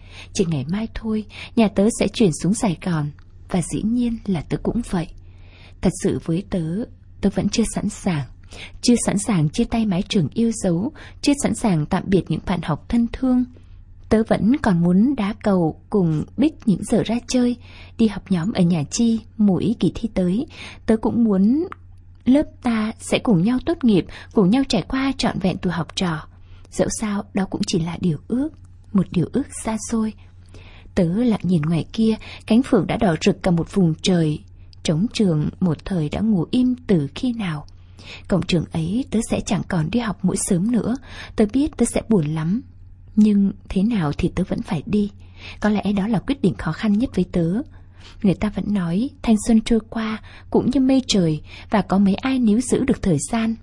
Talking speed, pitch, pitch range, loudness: 205 wpm, 195 Hz, 165-225 Hz, -21 LUFS